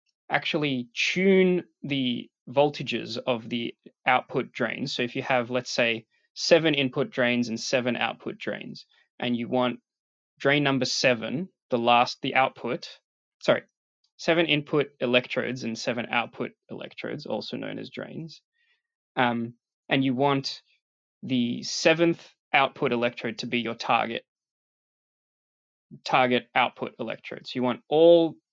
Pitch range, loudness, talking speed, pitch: 120-150 Hz, -26 LUFS, 130 wpm, 130 Hz